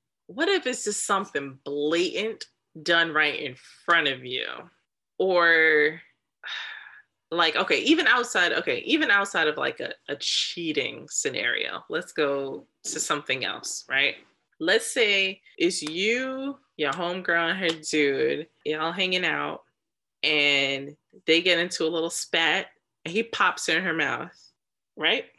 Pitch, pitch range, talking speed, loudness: 170 Hz, 155-255 Hz, 135 wpm, -24 LUFS